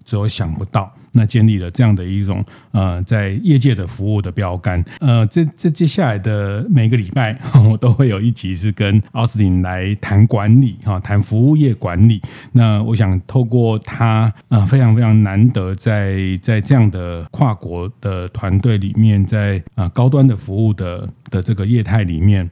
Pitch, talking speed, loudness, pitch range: 110 Hz, 265 characters per minute, -15 LUFS, 100-120 Hz